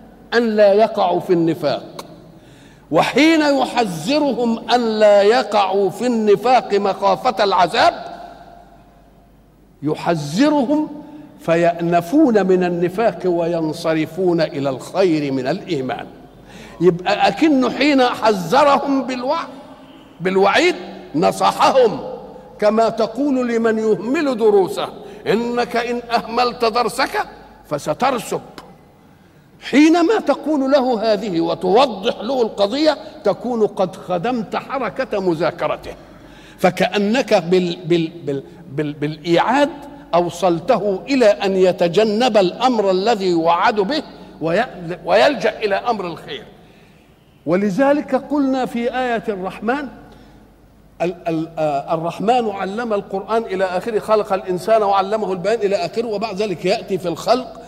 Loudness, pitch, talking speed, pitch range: -17 LUFS, 215 Hz, 95 wpm, 180-255 Hz